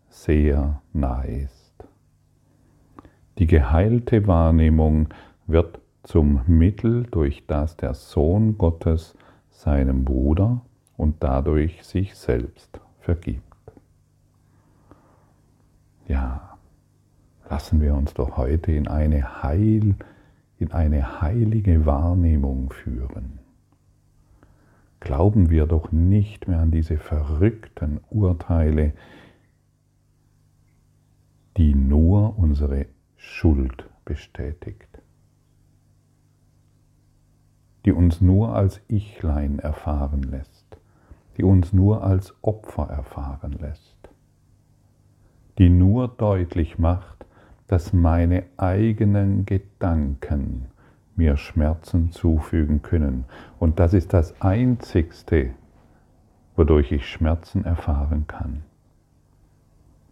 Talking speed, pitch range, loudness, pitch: 85 wpm, 75-100 Hz, -22 LUFS, 85 Hz